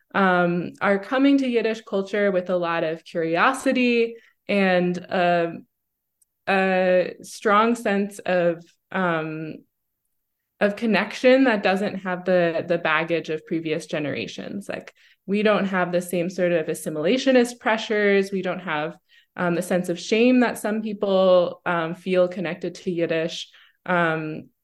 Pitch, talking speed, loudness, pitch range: 185 Hz, 135 wpm, -22 LUFS, 170-210 Hz